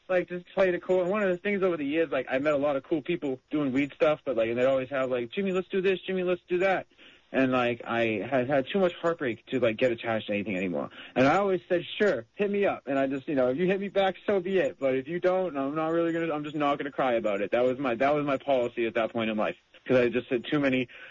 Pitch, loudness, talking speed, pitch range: 150 Hz, -28 LUFS, 305 wpm, 130-185 Hz